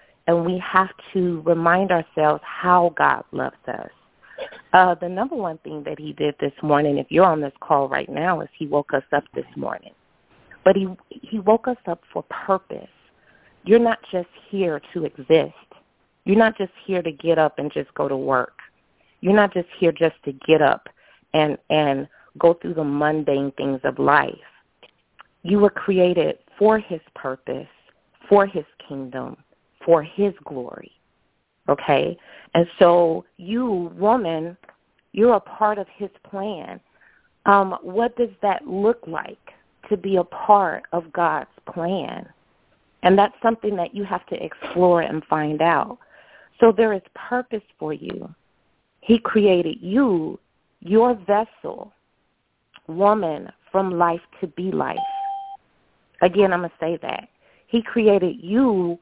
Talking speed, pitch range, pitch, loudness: 150 wpm, 165-210 Hz, 180 Hz, -21 LUFS